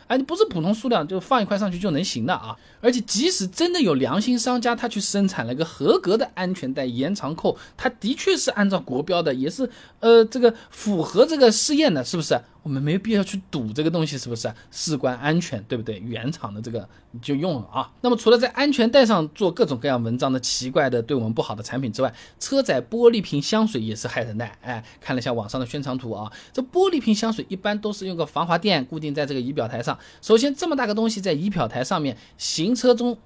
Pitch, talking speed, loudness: 185 Hz, 355 characters per minute, -22 LUFS